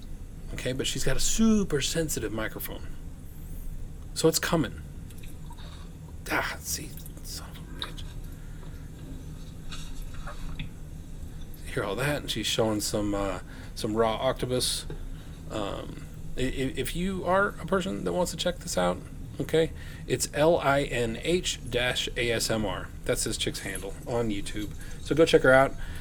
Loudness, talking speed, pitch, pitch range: -28 LUFS, 135 wpm, 110 Hz, 85-140 Hz